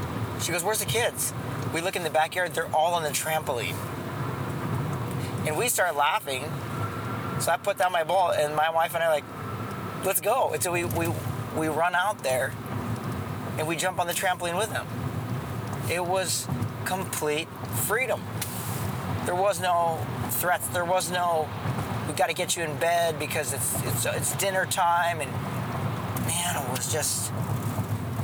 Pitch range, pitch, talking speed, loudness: 125-170 Hz, 140 Hz, 170 wpm, -27 LUFS